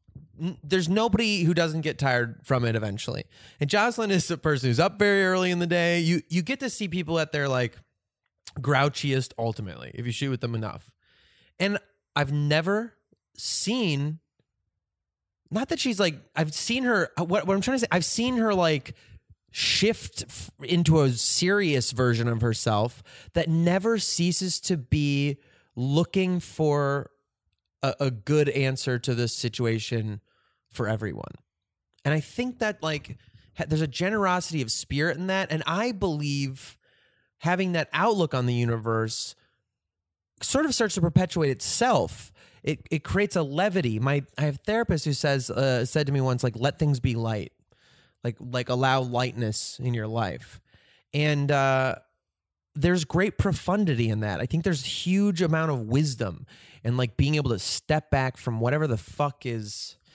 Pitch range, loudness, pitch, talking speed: 120-175 Hz, -25 LUFS, 145 Hz, 165 wpm